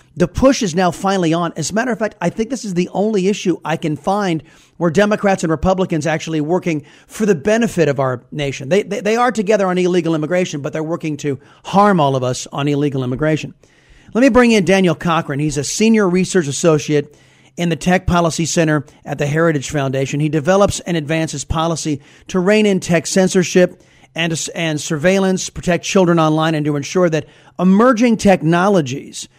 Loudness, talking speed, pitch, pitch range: -16 LUFS, 195 wpm, 170 Hz, 150-190 Hz